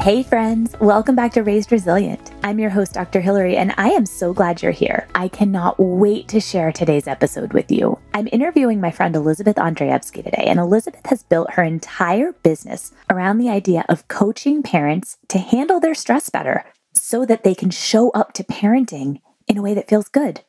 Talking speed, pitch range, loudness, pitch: 195 wpm, 185-235 Hz, -18 LUFS, 210 Hz